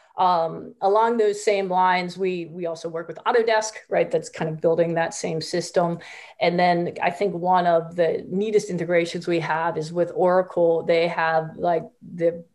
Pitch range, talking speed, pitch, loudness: 165-185 Hz, 175 wpm, 175 Hz, -23 LUFS